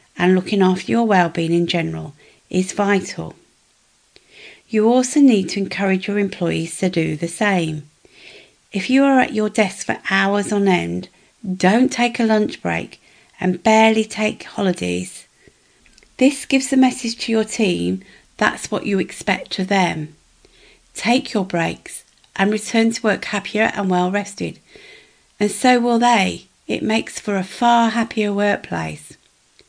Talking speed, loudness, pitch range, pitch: 150 wpm, -18 LUFS, 185-235 Hz, 205 Hz